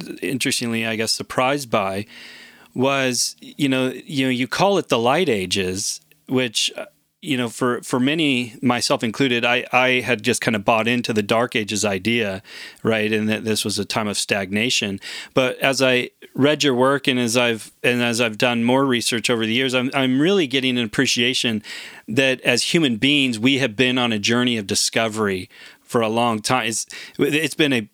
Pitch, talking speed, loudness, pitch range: 125 Hz, 190 wpm, -19 LUFS, 115-130 Hz